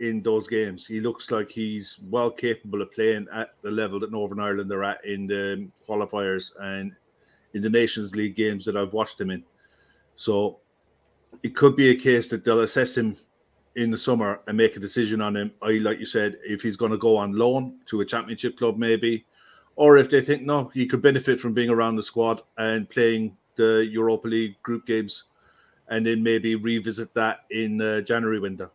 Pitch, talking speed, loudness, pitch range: 110 Hz, 200 wpm, -24 LUFS, 105-115 Hz